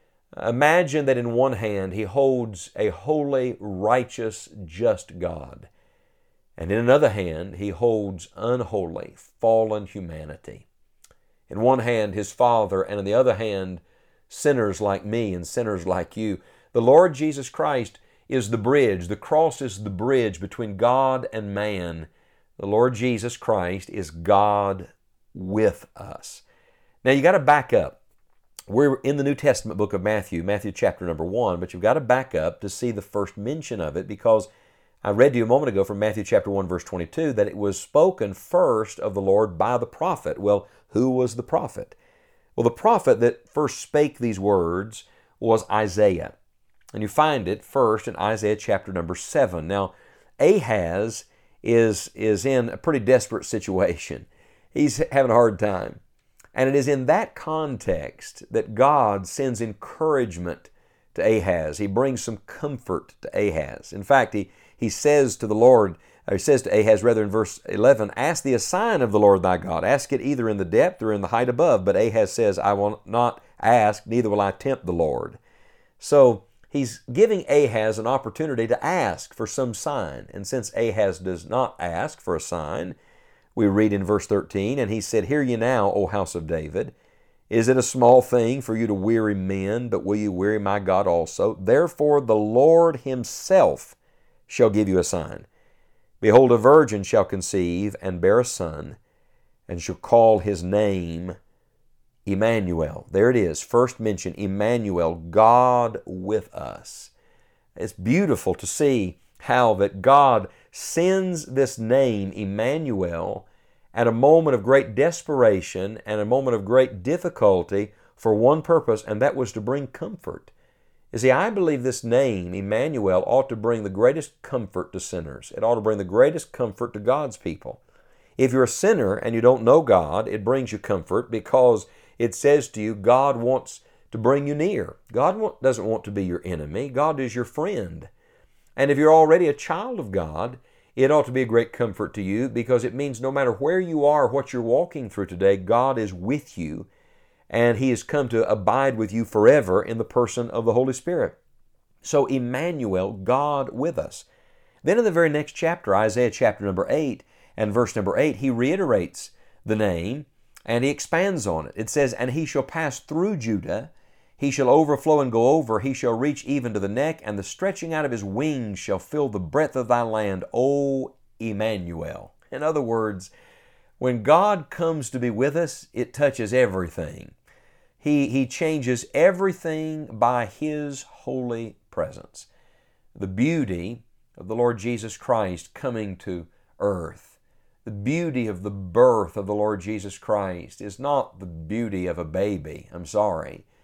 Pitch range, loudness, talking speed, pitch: 100-135 Hz, -22 LUFS, 175 wpm, 115 Hz